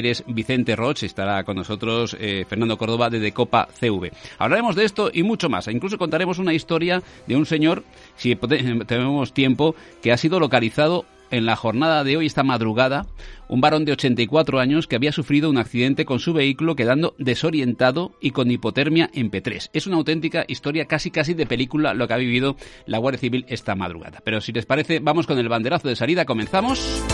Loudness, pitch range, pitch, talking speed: -21 LUFS, 115-155 Hz, 130 Hz, 190 wpm